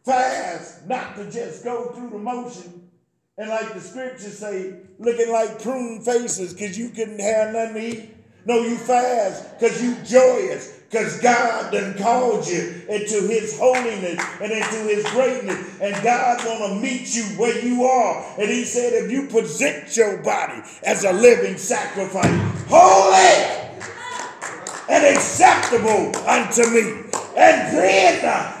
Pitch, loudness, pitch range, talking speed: 230 Hz, -19 LUFS, 210-245 Hz, 145 wpm